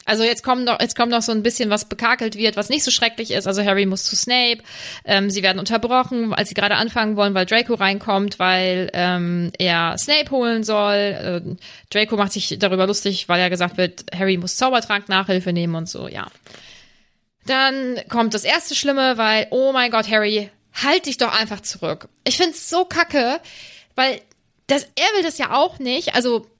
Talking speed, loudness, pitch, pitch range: 195 wpm, -18 LUFS, 220 Hz, 195-255 Hz